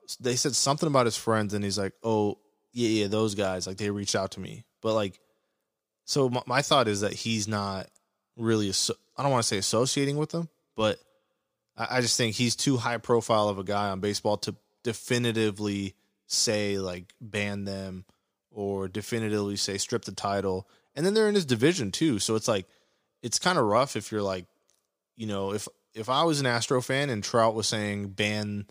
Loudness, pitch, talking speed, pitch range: -27 LUFS, 105 Hz, 200 wpm, 100-120 Hz